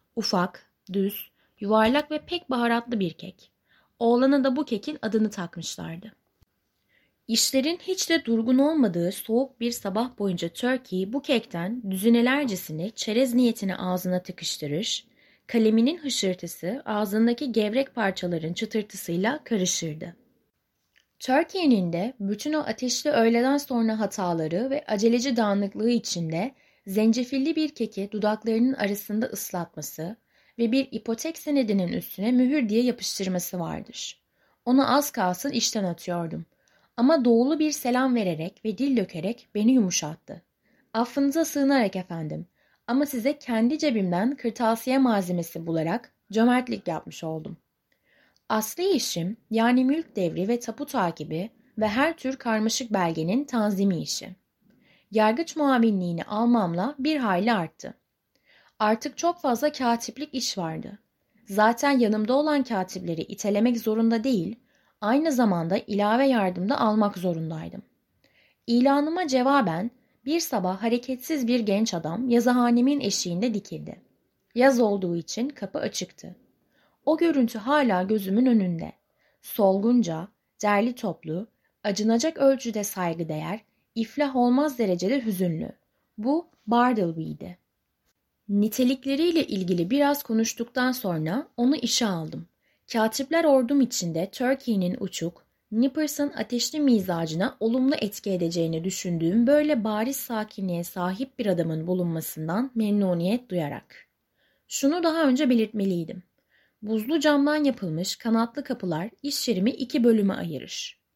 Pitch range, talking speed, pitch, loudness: 190-260 Hz, 115 wpm, 225 Hz, -25 LUFS